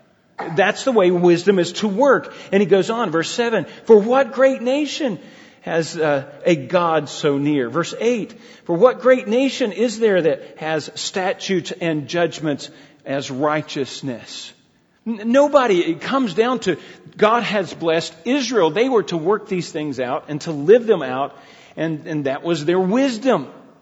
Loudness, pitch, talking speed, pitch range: -19 LUFS, 185 Hz, 165 wpm, 155-245 Hz